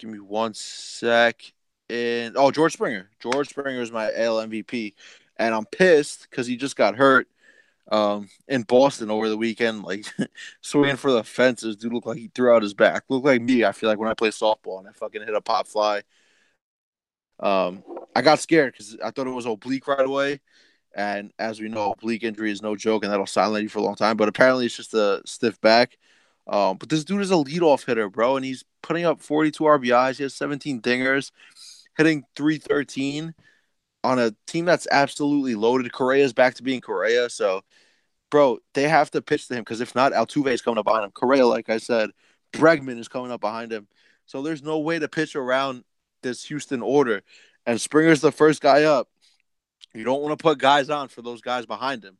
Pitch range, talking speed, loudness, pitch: 110-145 Hz, 210 wpm, -22 LUFS, 125 Hz